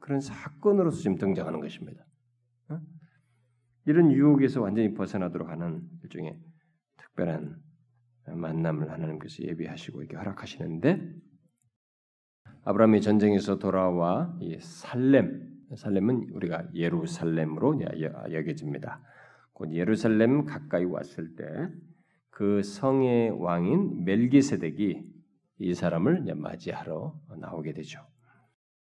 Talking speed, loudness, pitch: 265 characters per minute, -28 LUFS, 120 Hz